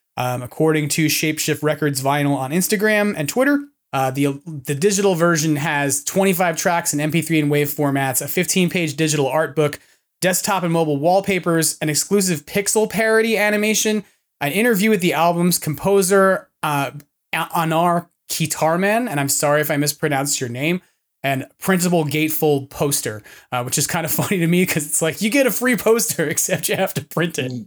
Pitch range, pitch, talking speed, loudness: 145-190 Hz, 160 Hz, 175 wpm, -18 LUFS